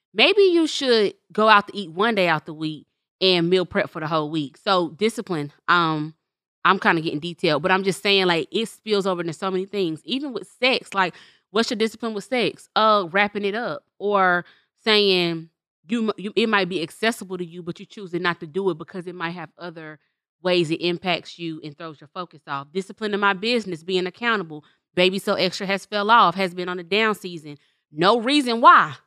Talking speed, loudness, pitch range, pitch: 215 wpm, -21 LUFS, 170-210 Hz, 185 Hz